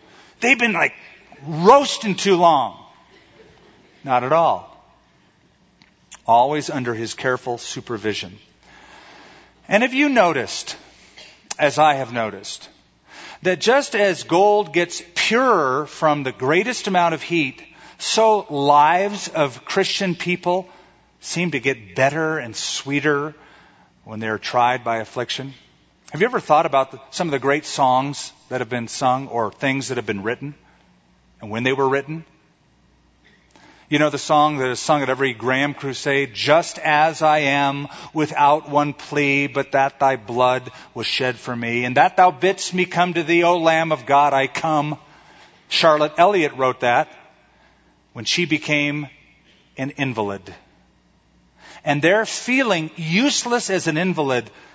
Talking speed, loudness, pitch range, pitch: 145 wpm, -19 LUFS, 125-170 Hz, 145 Hz